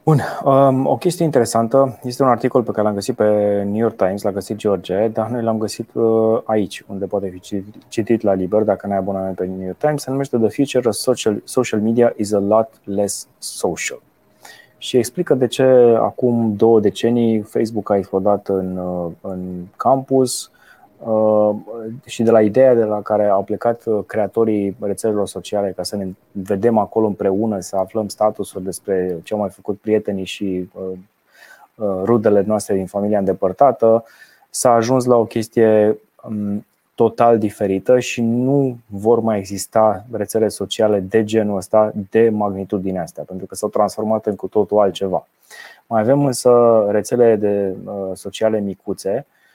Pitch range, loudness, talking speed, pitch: 100-115 Hz, -18 LUFS, 160 wpm, 105 Hz